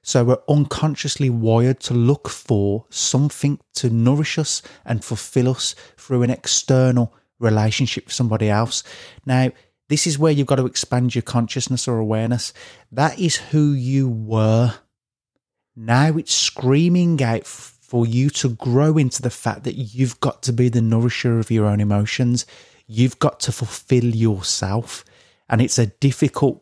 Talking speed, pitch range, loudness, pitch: 155 wpm, 115-135 Hz, -19 LUFS, 125 Hz